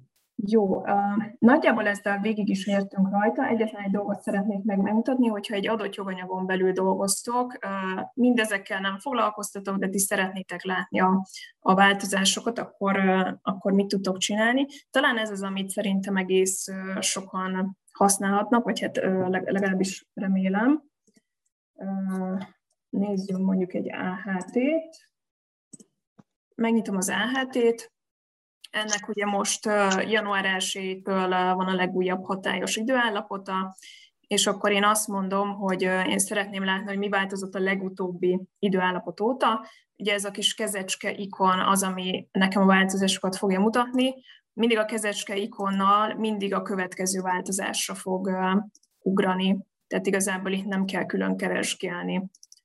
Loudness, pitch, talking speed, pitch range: -25 LUFS, 200 Hz, 130 wpm, 190-215 Hz